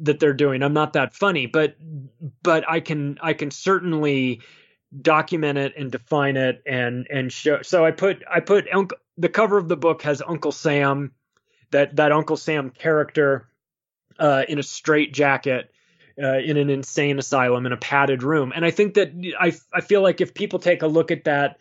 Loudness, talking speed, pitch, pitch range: -21 LUFS, 195 wpm, 150 Hz, 140-165 Hz